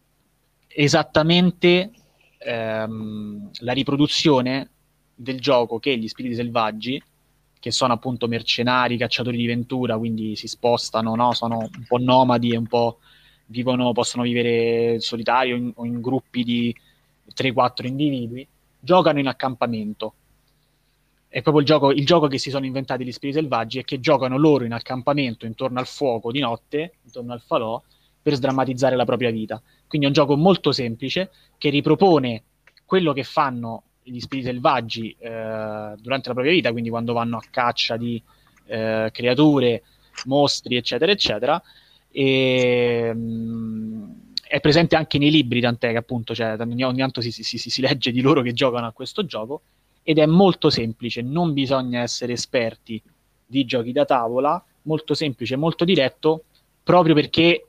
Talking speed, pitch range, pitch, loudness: 150 wpm, 120-145 Hz, 130 Hz, -21 LUFS